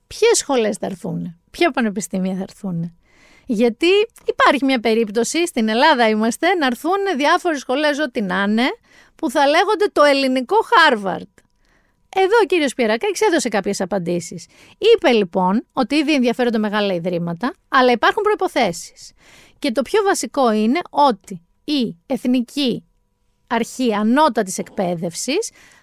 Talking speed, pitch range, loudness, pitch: 130 wpm, 215-325 Hz, -18 LUFS, 255 Hz